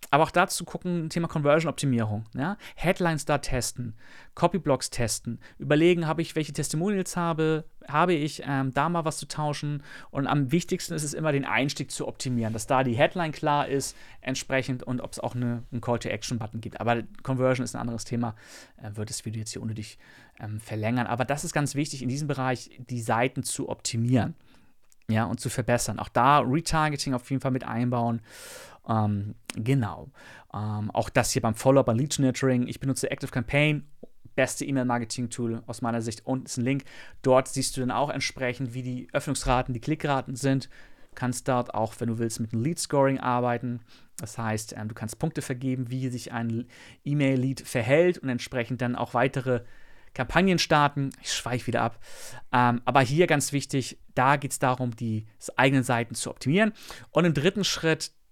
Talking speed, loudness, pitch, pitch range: 185 wpm, -27 LUFS, 130 Hz, 120-145 Hz